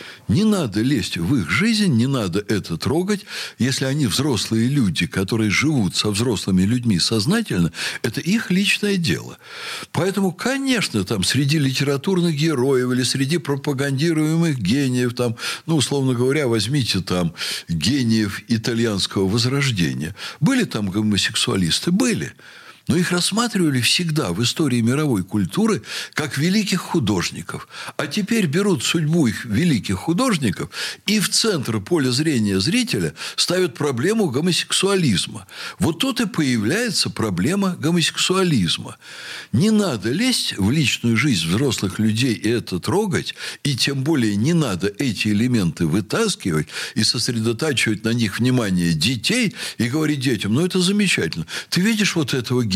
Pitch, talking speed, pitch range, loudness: 140 Hz, 130 wpm, 110-180 Hz, -20 LUFS